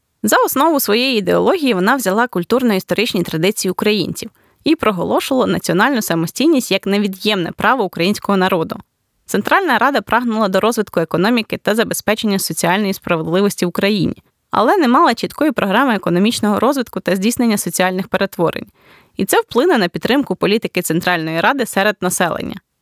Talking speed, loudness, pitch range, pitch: 135 wpm, -16 LUFS, 185-245 Hz, 205 Hz